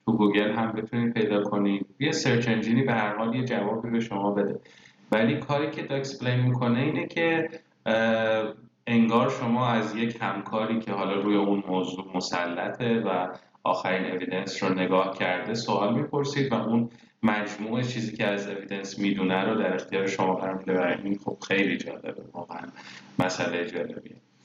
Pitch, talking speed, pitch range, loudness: 110 Hz, 160 wpm, 100-120 Hz, -27 LUFS